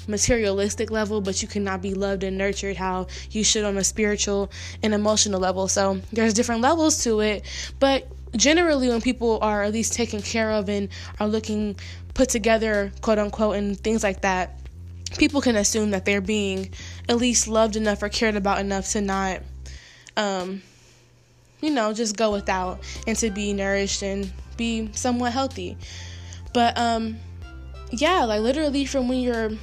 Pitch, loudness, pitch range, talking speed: 210 Hz, -23 LUFS, 190-225 Hz, 170 wpm